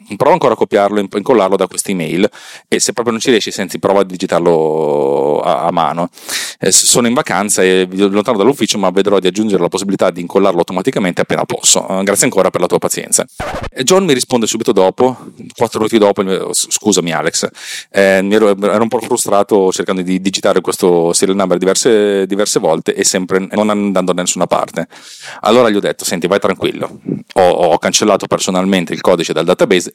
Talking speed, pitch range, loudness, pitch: 190 wpm, 95-105 Hz, -13 LUFS, 100 Hz